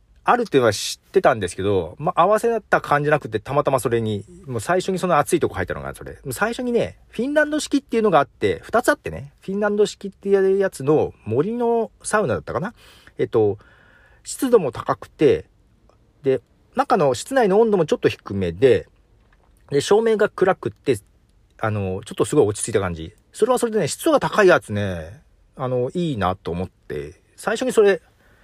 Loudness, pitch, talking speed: -21 LUFS, 185 Hz, 380 characters per minute